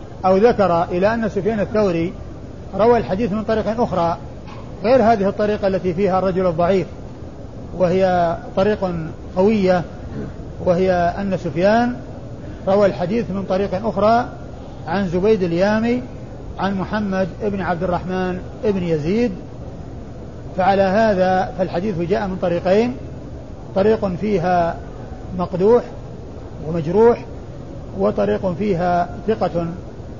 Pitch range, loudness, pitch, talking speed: 175-210 Hz, -19 LUFS, 185 Hz, 105 wpm